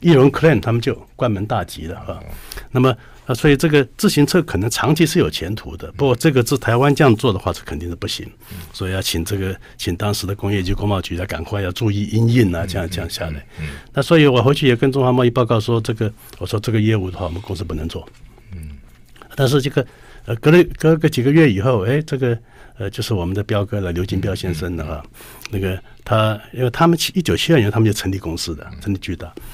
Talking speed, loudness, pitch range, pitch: 355 characters per minute, -18 LUFS, 95-130 Hz, 110 Hz